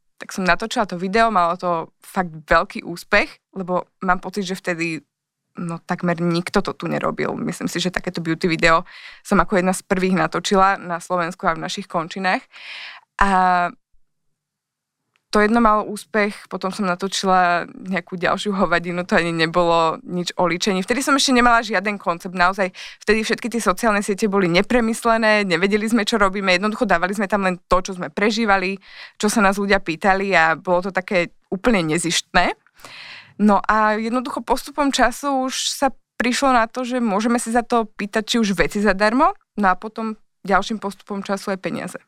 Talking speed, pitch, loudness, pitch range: 175 wpm, 195 Hz, -19 LUFS, 180-220 Hz